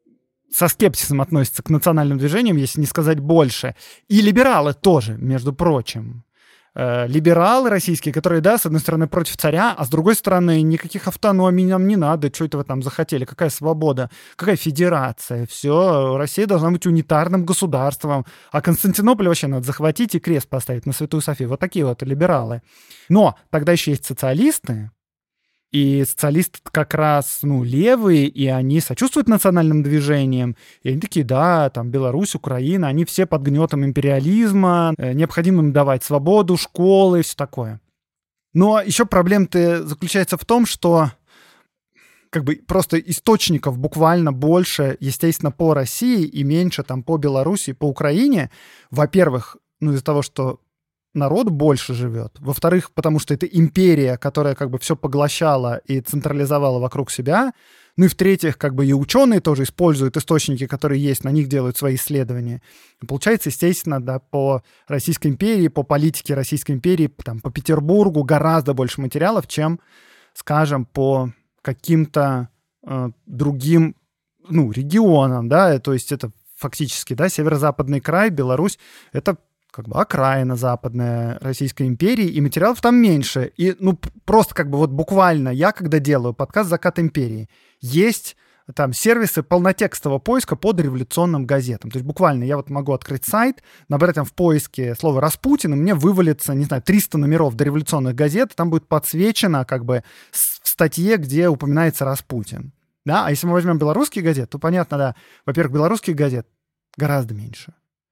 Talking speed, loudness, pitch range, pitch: 155 wpm, -18 LUFS, 135-175 Hz, 150 Hz